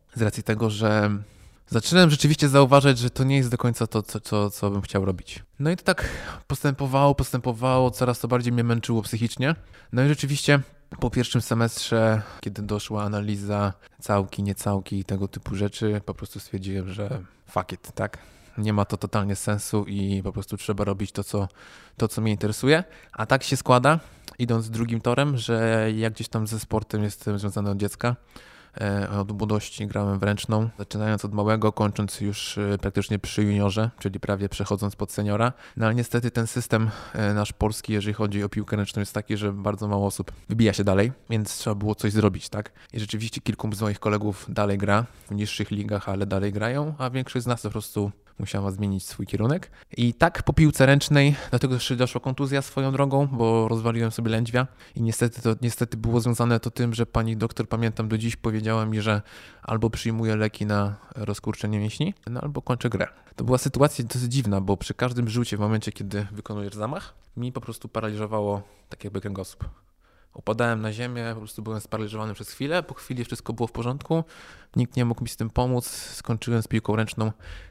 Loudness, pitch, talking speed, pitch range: -25 LUFS, 110 Hz, 190 wpm, 105-120 Hz